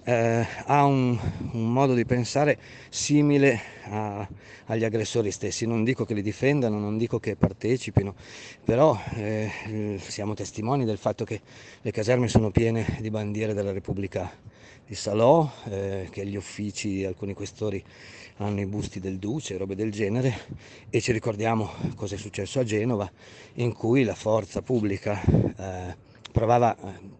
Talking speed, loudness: 150 wpm, -26 LUFS